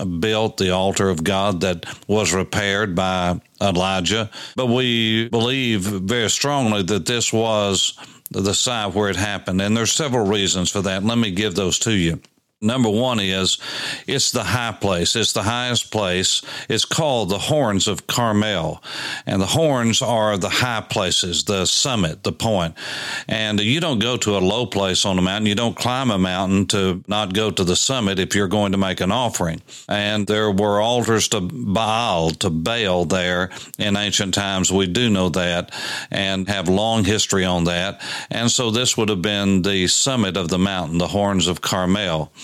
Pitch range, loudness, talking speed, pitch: 95-110 Hz, -19 LUFS, 180 wpm, 100 Hz